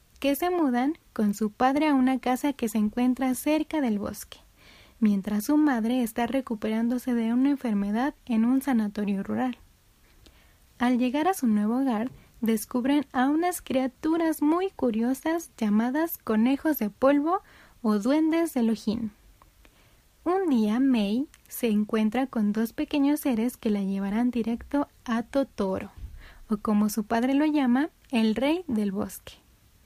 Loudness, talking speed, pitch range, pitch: -26 LUFS, 145 wpm, 220-285 Hz, 250 Hz